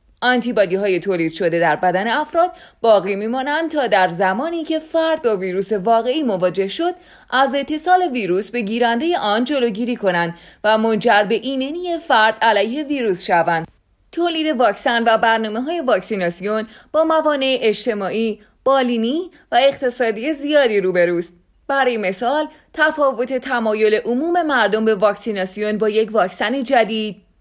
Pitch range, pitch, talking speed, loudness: 205-280 Hz, 230 Hz, 135 wpm, -18 LUFS